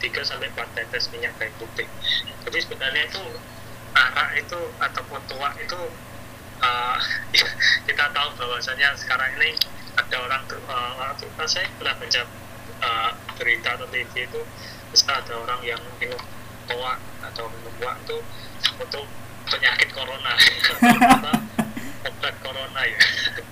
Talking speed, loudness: 130 wpm, -22 LUFS